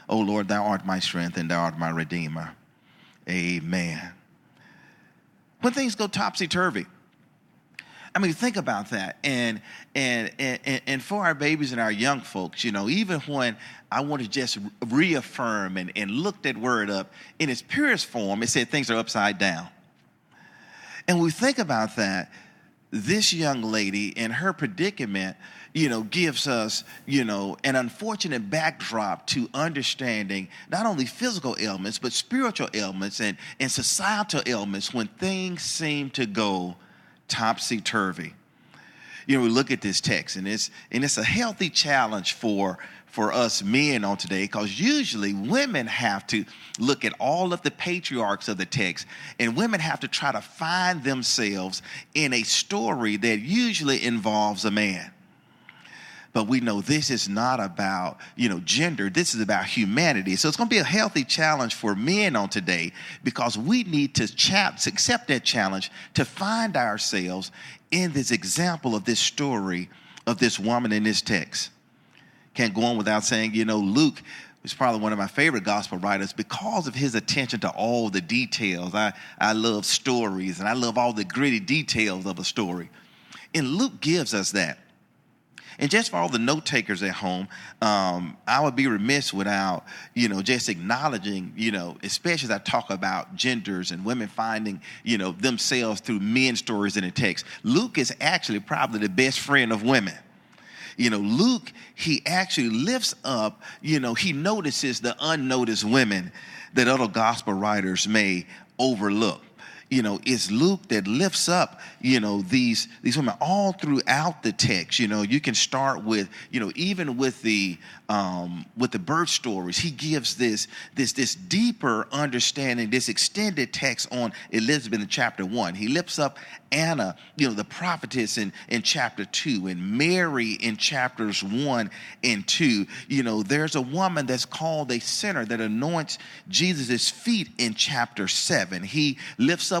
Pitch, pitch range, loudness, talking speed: 120 Hz, 105-150 Hz, -25 LUFS, 170 wpm